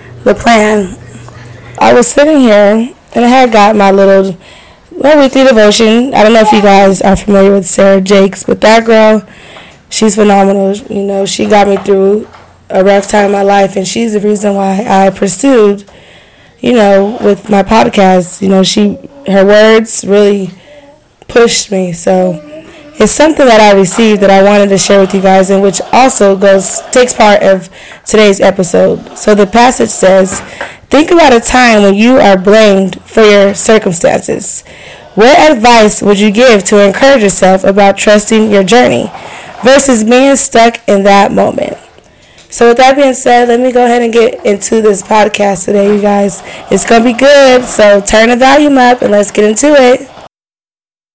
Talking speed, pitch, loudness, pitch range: 175 wpm, 210 Hz, -6 LUFS, 195-240 Hz